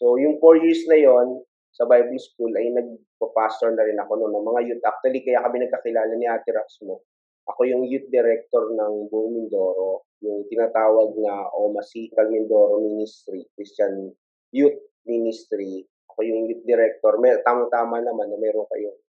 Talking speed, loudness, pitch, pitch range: 165 wpm, -21 LUFS, 120 Hz, 110-165 Hz